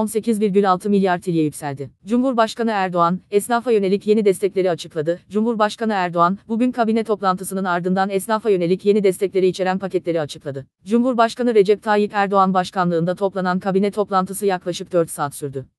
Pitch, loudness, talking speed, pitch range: 190 Hz, -19 LUFS, 135 wpm, 180-215 Hz